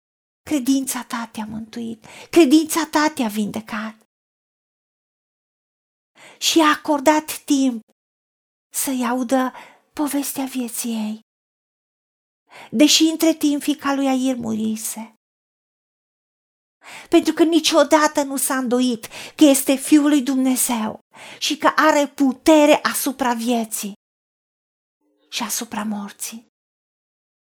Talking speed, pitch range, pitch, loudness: 95 wpm, 230-300 Hz, 265 Hz, -19 LUFS